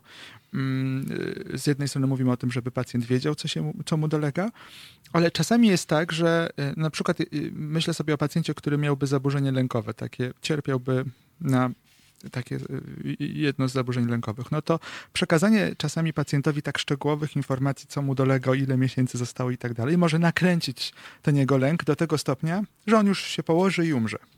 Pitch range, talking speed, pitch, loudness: 130-165 Hz, 170 wpm, 150 Hz, -25 LUFS